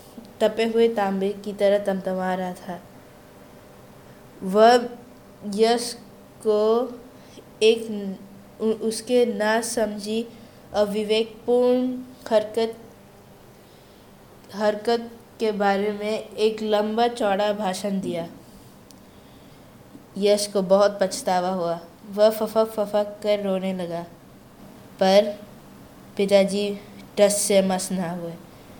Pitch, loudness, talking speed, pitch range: 210 Hz, -23 LUFS, 90 wpm, 195-220 Hz